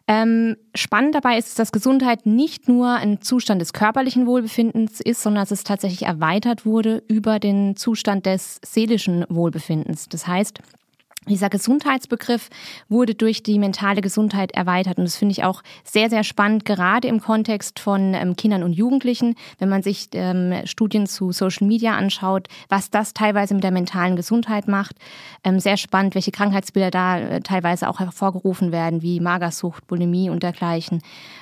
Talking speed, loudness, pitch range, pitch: 155 wpm, -20 LUFS, 185-225 Hz, 200 Hz